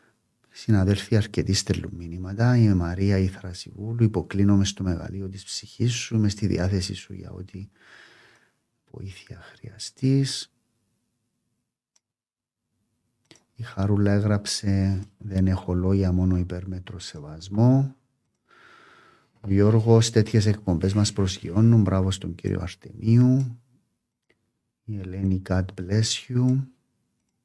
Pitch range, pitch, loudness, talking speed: 95-115 Hz, 105 Hz, -23 LUFS, 100 wpm